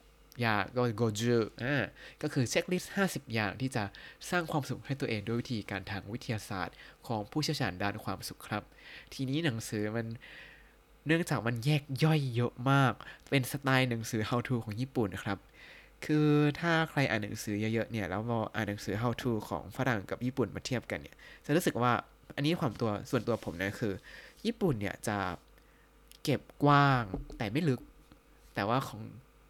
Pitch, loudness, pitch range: 120 Hz, -33 LUFS, 110-145 Hz